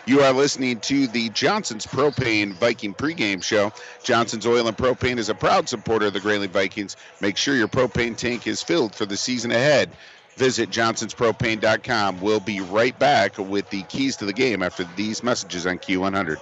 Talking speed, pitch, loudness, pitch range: 185 wpm, 110 Hz, -22 LUFS, 100-125 Hz